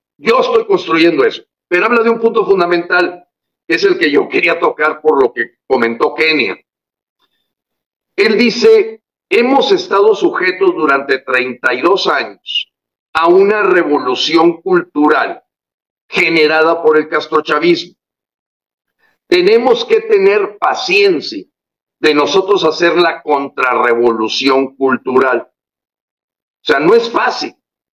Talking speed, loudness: 115 wpm, -12 LUFS